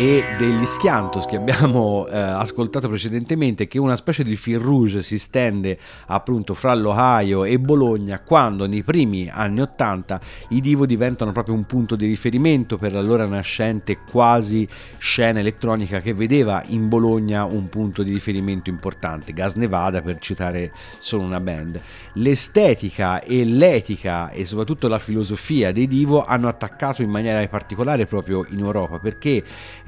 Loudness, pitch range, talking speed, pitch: -19 LUFS, 100-125 Hz, 150 wpm, 110 Hz